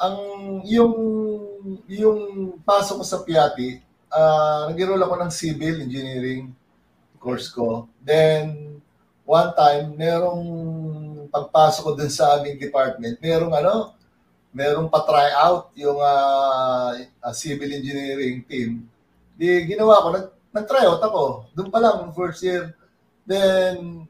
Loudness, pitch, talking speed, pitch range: -20 LUFS, 155 Hz, 120 wpm, 135-185 Hz